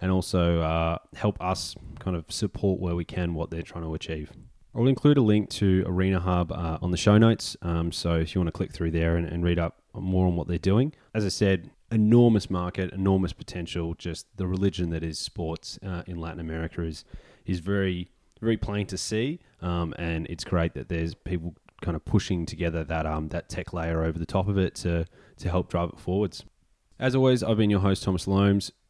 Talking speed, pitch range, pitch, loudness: 220 wpm, 85-100 Hz, 90 Hz, -27 LUFS